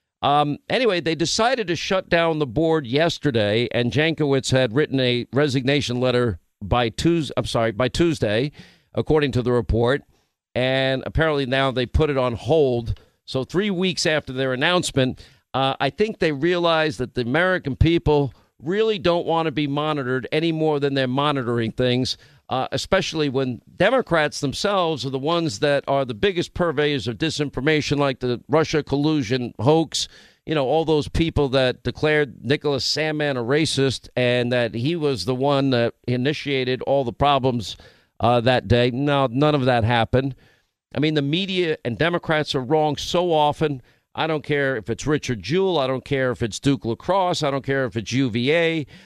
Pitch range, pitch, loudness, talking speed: 125-155 Hz, 140 Hz, -21 LUFS, 175 wpm